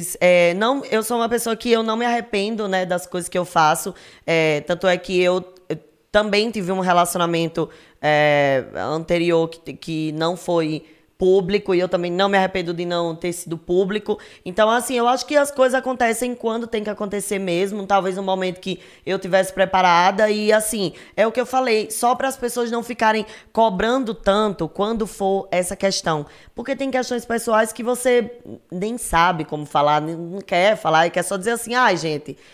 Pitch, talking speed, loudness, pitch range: 195 Hz, 190 wpm, -20 LUFS, 170-225 Hz